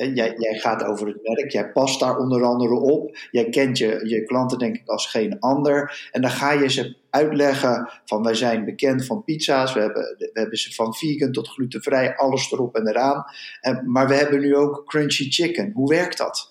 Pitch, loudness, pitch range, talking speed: 130 Hz, -21 LUFS, 120-145 Hz, 215 wpm